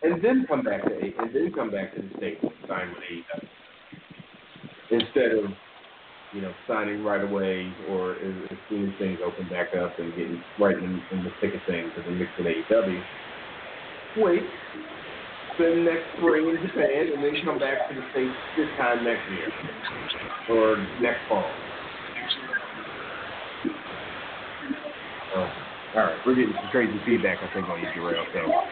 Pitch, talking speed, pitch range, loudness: 105 Hz, 165 wpm, 90-130 Hz, -27 LUFS